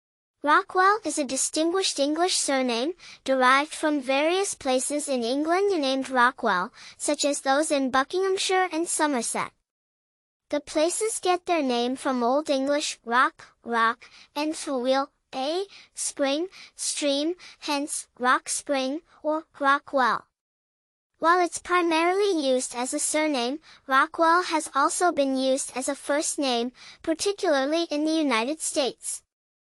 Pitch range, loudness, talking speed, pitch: 265-330 Hz, -25 LUFS, 130 wpm, 295 Hz